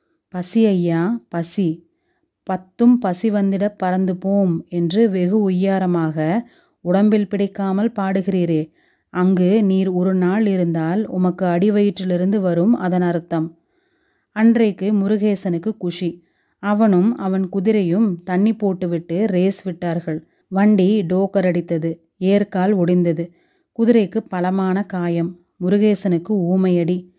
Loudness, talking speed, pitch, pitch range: -18 LUFS, 100 wpm, 190 Hz, 175-210 Hz